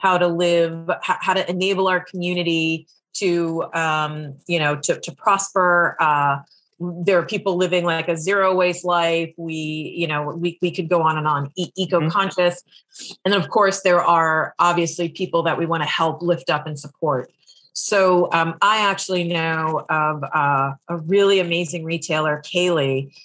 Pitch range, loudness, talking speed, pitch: 160-180 Hz, -20 LUFS, 170 wpm, 170 Hz